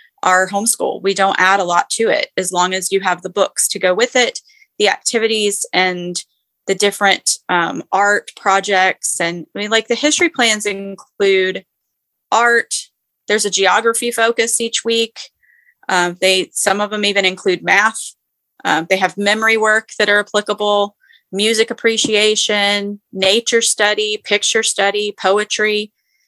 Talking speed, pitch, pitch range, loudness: 150 wpm, 205 Hz, 195-225 Hz, -15 LUFS